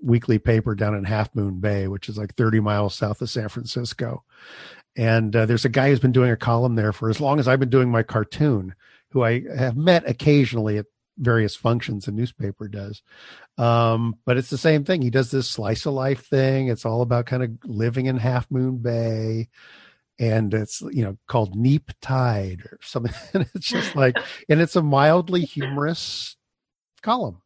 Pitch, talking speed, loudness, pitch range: 120 Hz, 195 wpm, -22 LUFS, 110-130 Hz